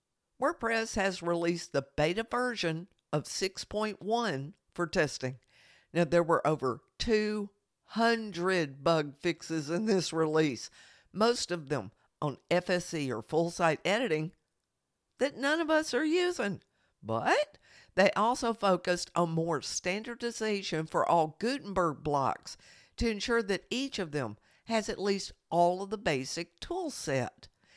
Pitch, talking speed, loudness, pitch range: 180 Hz, 130 wpm, -31 LUFS, 160-220 Hz